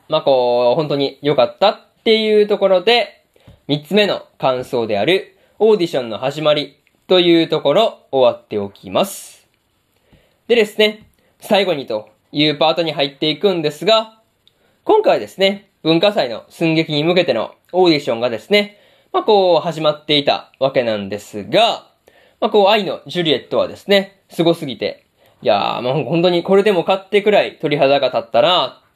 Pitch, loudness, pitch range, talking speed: 170 Hz, -16 LUFS, 145-205 Hz, 335 characters per minute